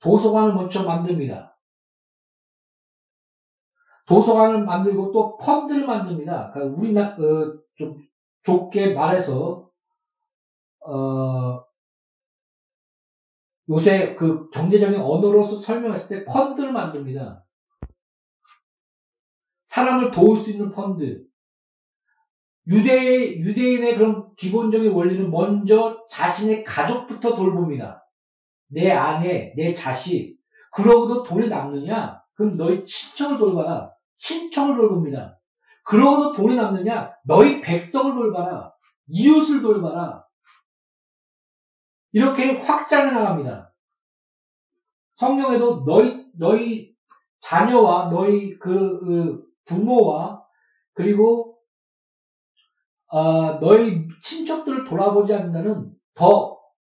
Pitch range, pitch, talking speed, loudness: 175-245 Hz, 210 Hz, 215 characters per minute, -19 LUFS